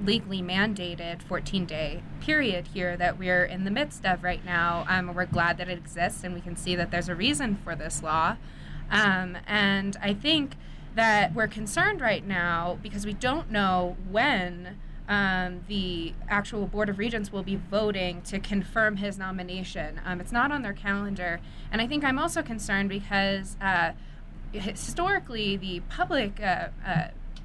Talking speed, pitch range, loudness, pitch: 170 wpm, 180-210 Hz, -28 LUFS, 195 Hz